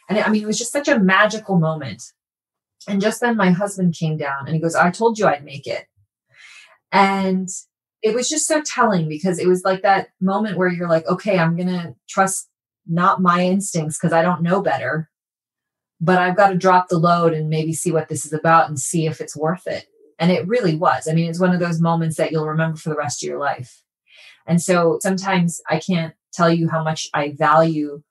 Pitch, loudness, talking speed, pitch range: 175 Hz, -19 LUFS, 225 wpm, 160-190 Hz